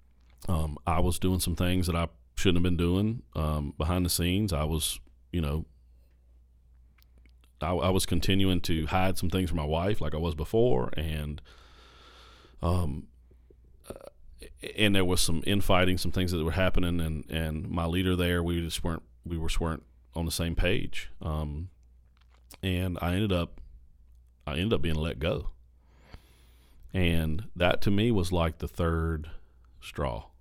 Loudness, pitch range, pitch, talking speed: -29 LUFS, 70-90 Hz, 80 Hz, 165 wpm